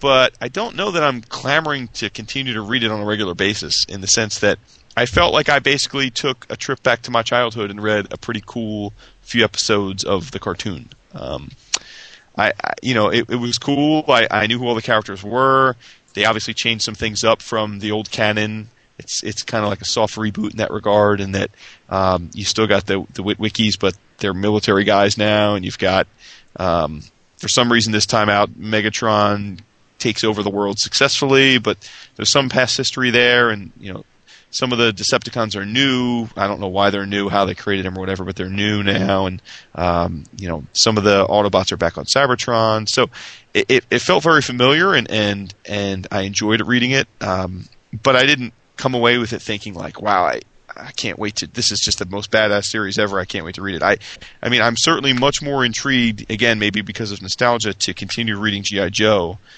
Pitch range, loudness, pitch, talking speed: 100-120 Hz, -17 LUFS, 105 Hz, 215 wpm